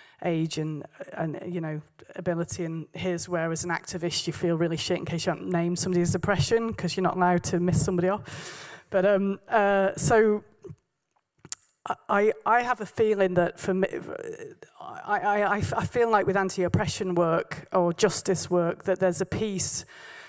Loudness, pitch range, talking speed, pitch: -26 LUFS, 170-205 Hz, 175 wpm, 180 Hz